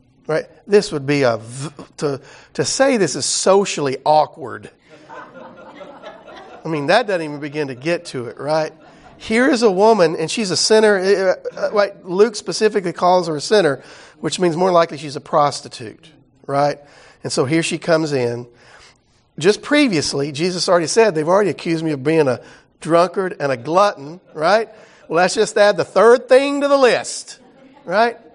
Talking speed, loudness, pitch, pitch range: 170 wpm, -17 LUFS, 175 Hz, 150-215 Hz